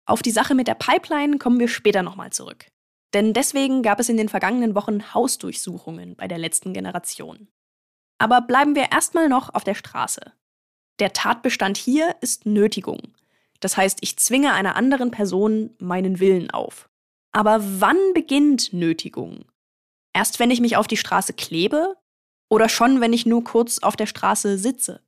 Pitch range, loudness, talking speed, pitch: 190-255 Hz, -20 LUFS, 165 wpm, 220 Hz